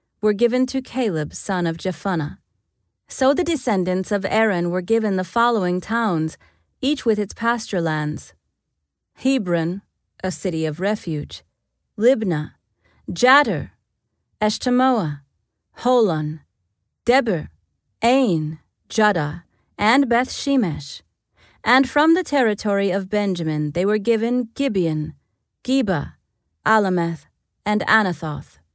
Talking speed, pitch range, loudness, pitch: 105 wpm, 160-240 Hz, -20 LUFS, 205 Hz